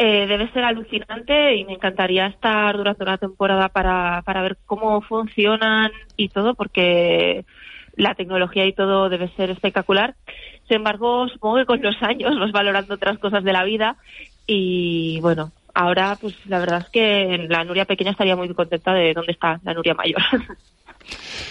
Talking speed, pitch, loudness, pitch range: 170 wpm, 195 Hz, -19 LUFS, 185-215 Hz